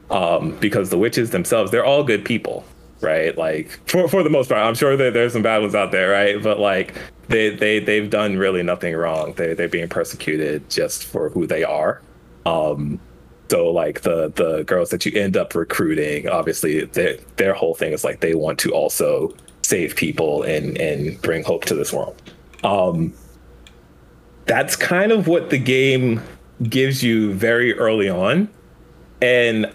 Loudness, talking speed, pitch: -19 LUFS, 180 wpm, 115 Hz